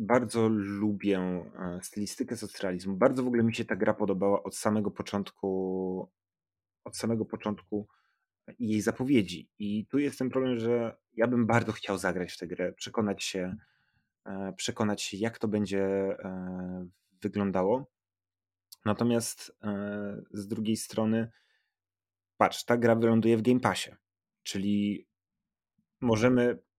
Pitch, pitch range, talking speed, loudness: 105 Hz, 95-115 Hz, 125 wpm, -30 LUFS